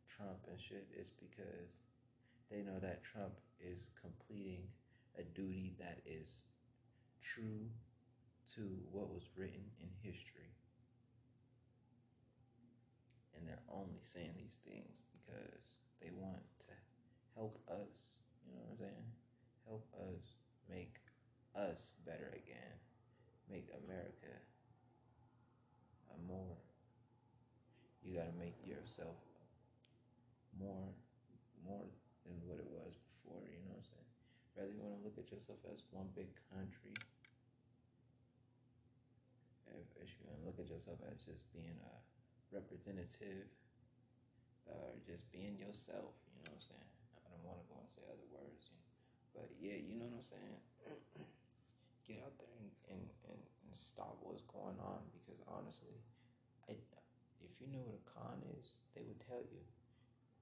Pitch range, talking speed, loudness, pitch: 100-125 Hz, 140 wpm, -55 LUFS, 120 Hz